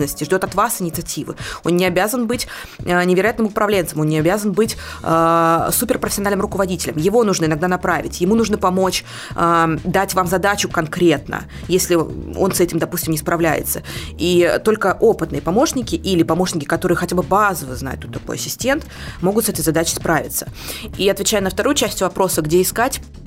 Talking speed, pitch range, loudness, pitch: 160 wpm, 165-205 Hz, -18 LUFS, 185 Hz